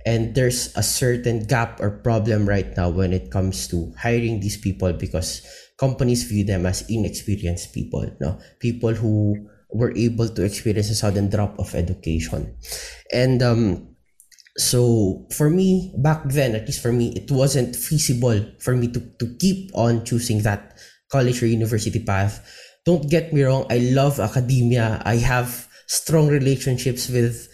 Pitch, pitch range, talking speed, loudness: 115 Hz, 105-125 Hz, 160 wpm, -21 LUFS